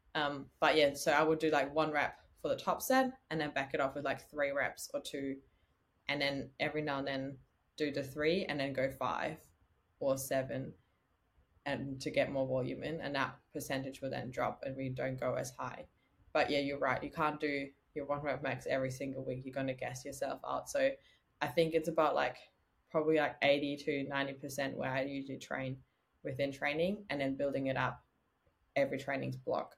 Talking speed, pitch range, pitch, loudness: 210 wpm, 135-150 Hz, 140 Hz, -36 LUFS